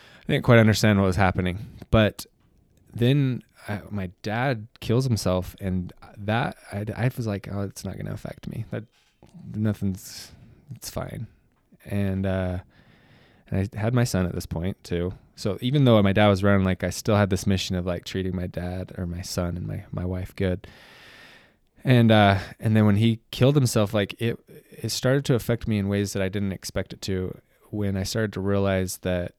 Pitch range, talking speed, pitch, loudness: 95-115 Hz, 195 wpm, 100 Hz, -25 LUFS